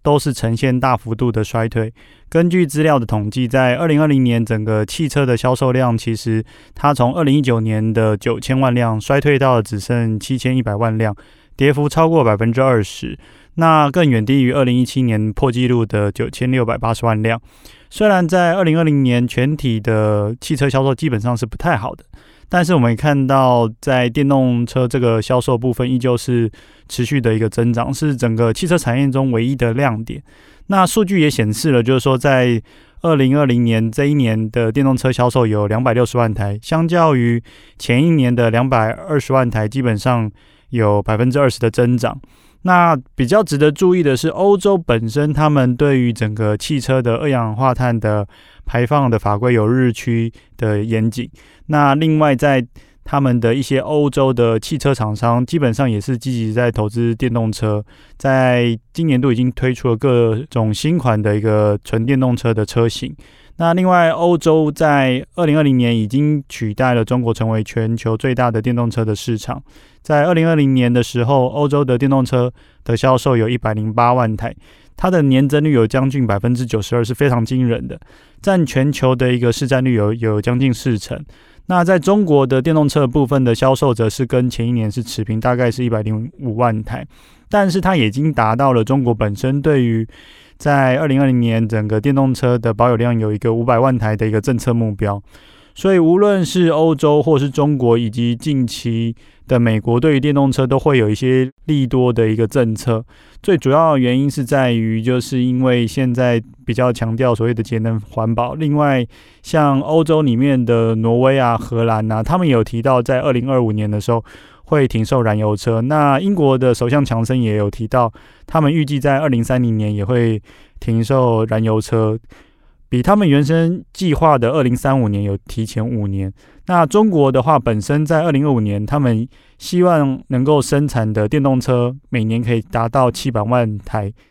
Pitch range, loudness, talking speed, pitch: 115-140 Hz, -16 LUFS, 285 characters per minute, 125 Hz